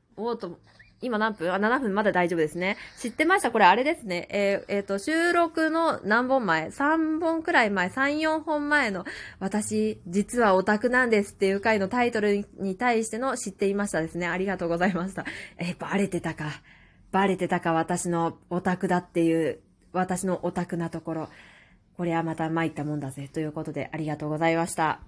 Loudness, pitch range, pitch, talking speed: -26 LUFS, 165-225 Hz, 190 Hz, 370 characters per minute